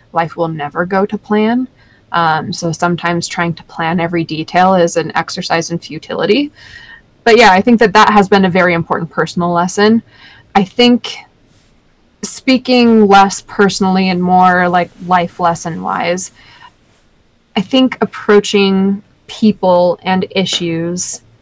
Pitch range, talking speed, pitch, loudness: 170-205 Hz, 135 wpm, 185 Hz, -12 LUFS